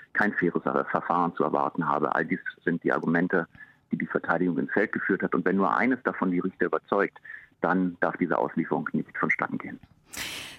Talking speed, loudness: 185 wpm, -27 LUFS